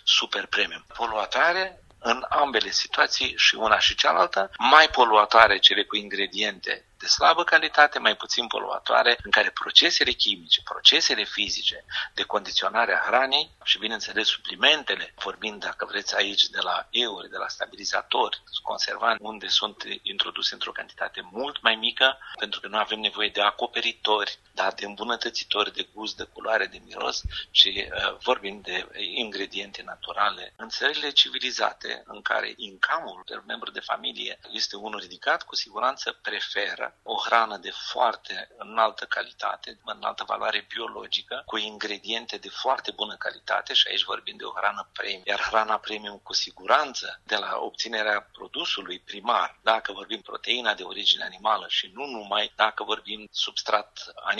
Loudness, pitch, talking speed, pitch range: -24 LUFS, 110 Hz, 150 wpm, 105-125 Hz